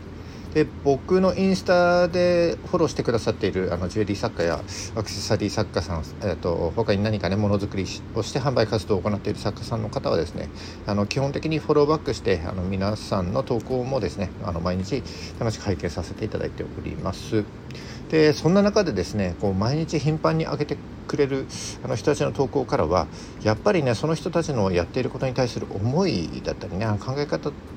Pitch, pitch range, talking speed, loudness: 110 Hz, 100-145 Hz, 405 characters per minute, -24 LUFS